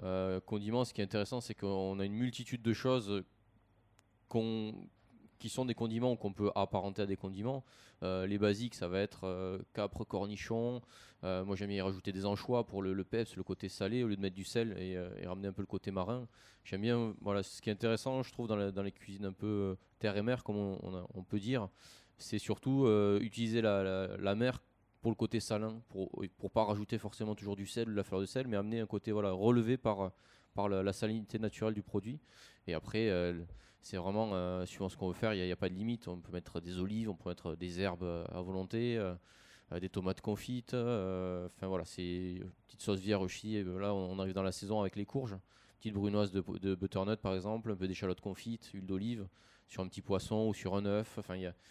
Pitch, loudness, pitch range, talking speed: 100 Hz, -38 LUFS, 95-110 Hz, 245 wpm